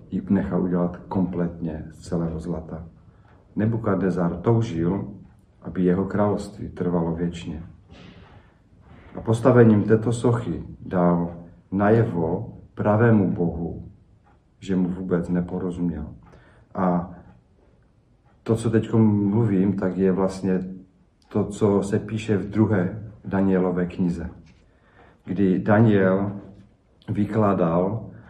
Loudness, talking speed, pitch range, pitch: -23 LUFS, 95 wpm, 90-105 Hz, 95 Hz